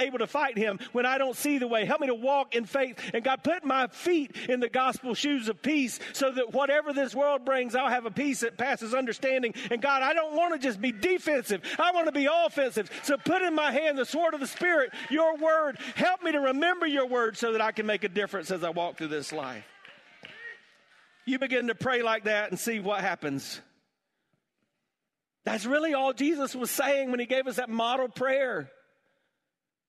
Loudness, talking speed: -28 LUFS, 215 wpm